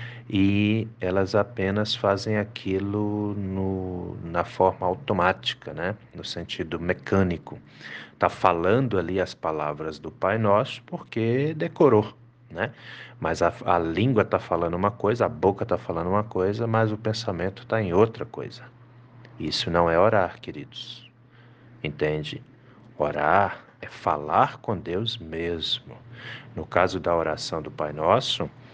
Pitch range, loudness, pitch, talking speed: 90-120 Hz, -25 LUFS, 105 Hz, 135 wpm